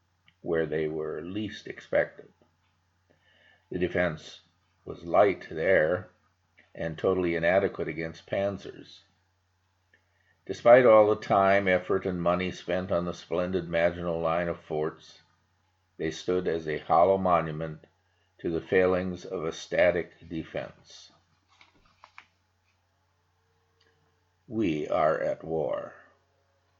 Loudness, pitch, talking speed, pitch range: -27 LUFS, 90 Hz, 105 wpm, 85-95 Hz